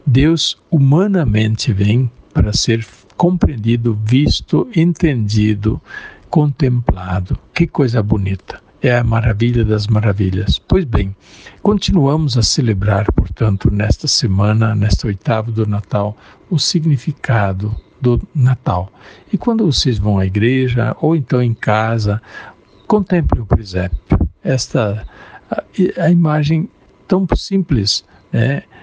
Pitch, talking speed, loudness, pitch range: 115 Hz, 110 wpm, -15 LUFS, 105-150 Hz